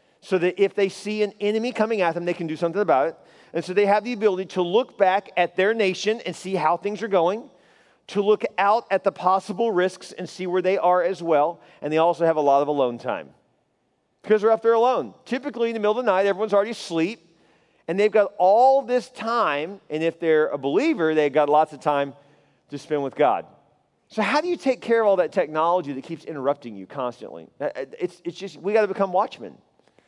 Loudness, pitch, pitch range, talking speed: -22 LUFS, 185 Hz, 160-210 Hz, 225 wpm